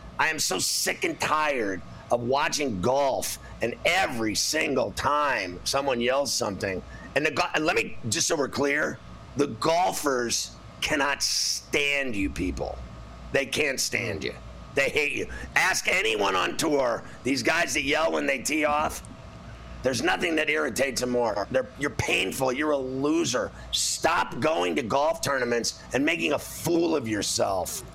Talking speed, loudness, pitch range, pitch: 155 wpm, -25 LUFS, 115-155 Hz, 130 Hz